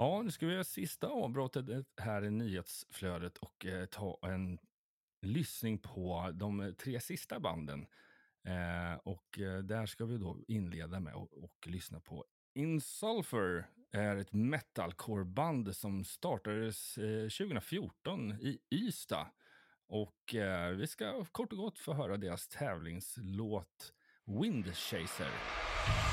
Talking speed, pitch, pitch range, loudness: 125 wpm, 105 Hz, 90-120 Hz, -40 LUFS